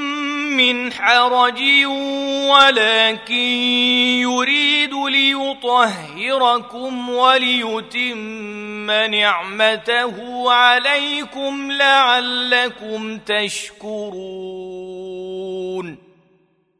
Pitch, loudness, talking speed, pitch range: 245 Hz, -15 LUFS, 35 wpm, 210-260 Hz